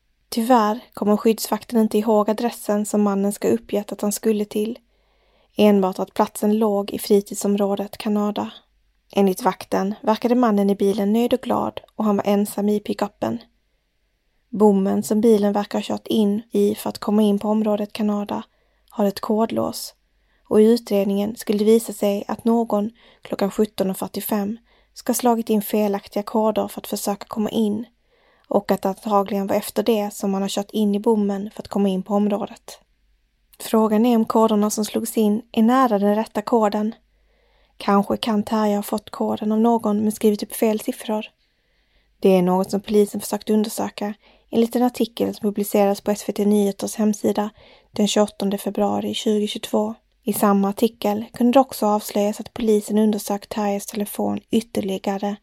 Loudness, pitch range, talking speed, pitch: -21 LUFS, 205-225 Hz, 170 wpm, 210 Hz